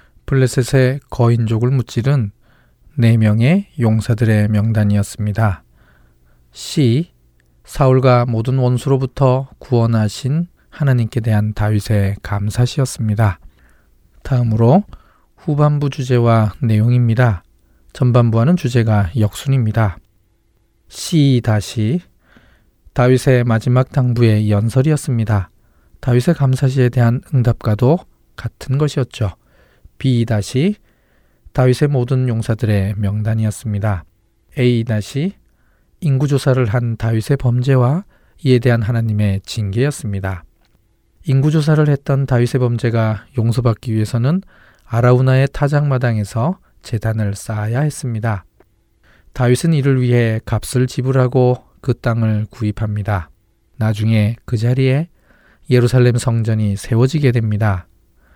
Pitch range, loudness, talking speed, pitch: 105-130 Hz, -16 LUFS, 255 characters per minute, 115 Hz